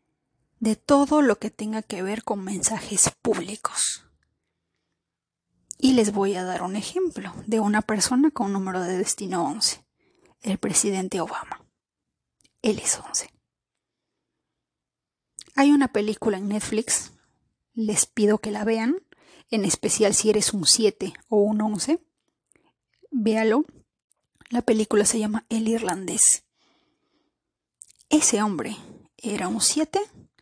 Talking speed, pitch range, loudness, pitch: 125 wpm, 205-255 Hz, -23 LUFS, 220 Hz